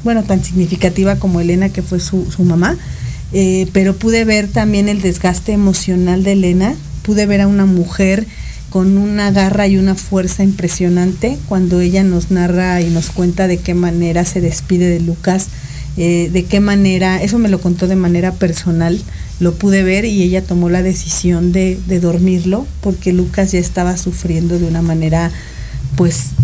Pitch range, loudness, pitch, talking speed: 175-195 Hz, -13 LUFS, 185 Hz, 175 wpm